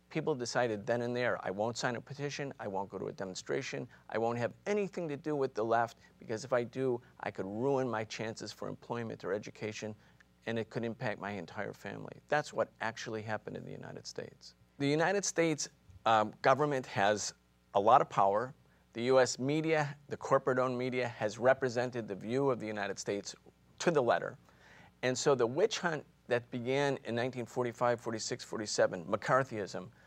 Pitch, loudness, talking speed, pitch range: 120 Hz, -34 LUFS, 185 wpm, 110-130 Hz